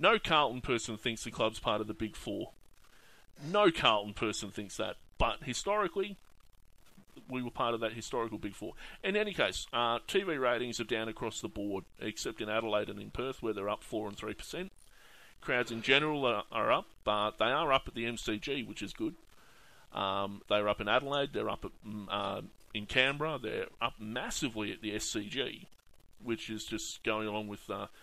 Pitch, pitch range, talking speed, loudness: 110 Hz, 105-125 Hz, 195 wpm, -34 LUFS